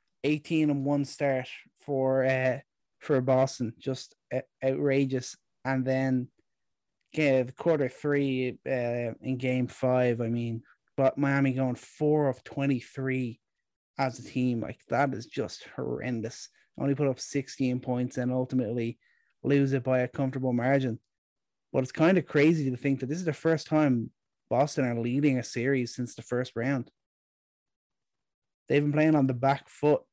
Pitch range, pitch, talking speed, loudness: 125-140 Hz, 130 Hz, 155 wpm, -29 LUFS